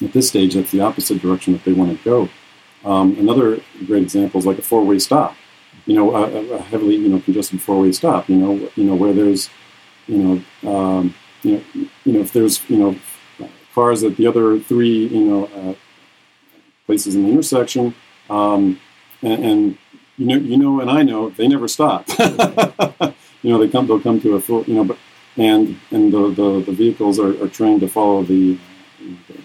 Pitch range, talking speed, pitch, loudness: 95-130 Hz, 175 wpm, 105 Hz, -16 LUFS